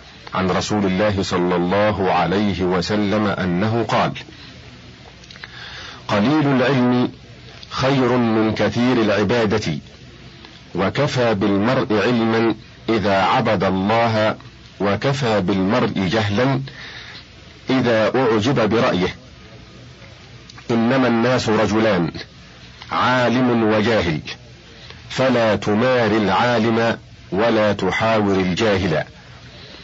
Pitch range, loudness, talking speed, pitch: 100-120 Hz, -18 LUFS, 75 wpm, 110 Hz